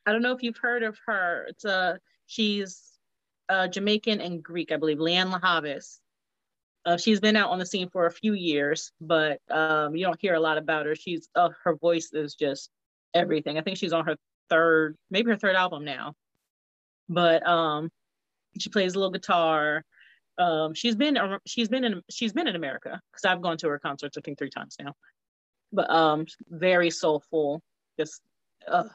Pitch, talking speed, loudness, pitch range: 170 Hz, 190 wpm, -26 LUFS, 155-195 Hz